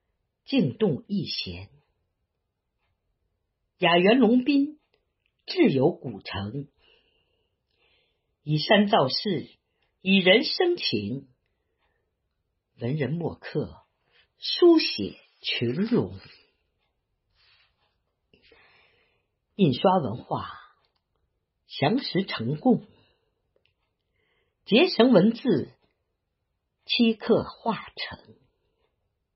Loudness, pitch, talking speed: -24 LUFS, 195 Hz, 90 characters per minute